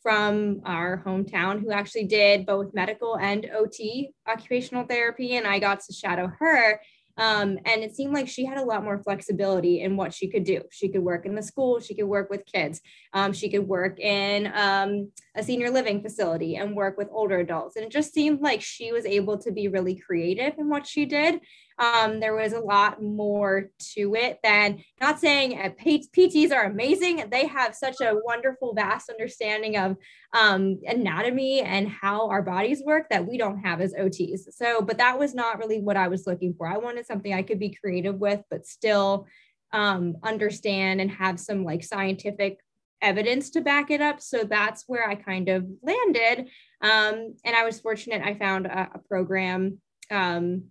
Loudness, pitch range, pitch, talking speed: -25 LUFS, 195-235 Hz, 210 Hz, 195 wpm